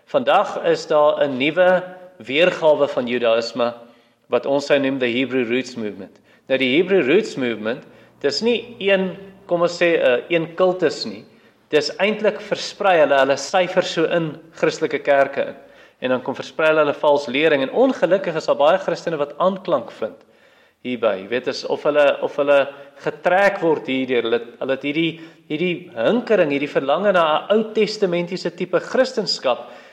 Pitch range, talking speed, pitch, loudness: 135-185 Hz, 170 wpm, 155 Hz, -19 LUFS